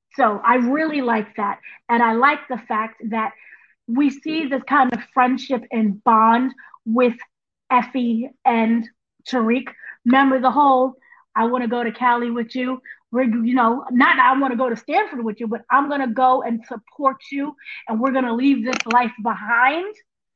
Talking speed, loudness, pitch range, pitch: 175 wpm, -19 LUFS, 230-270 Hz, 250 Hz